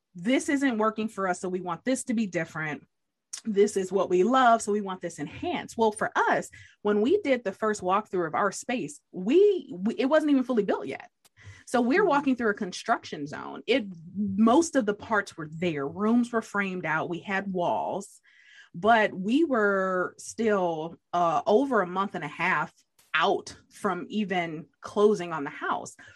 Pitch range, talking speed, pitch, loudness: 180-235 Hz, 185 wpm, 205 Hz, -27 LUFS